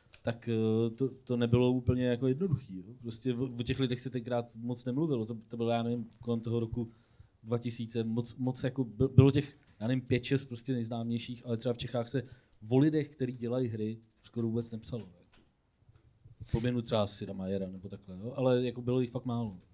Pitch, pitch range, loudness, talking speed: 120 Hz, 115-125 Hz, -33 LUFS, 190 wpm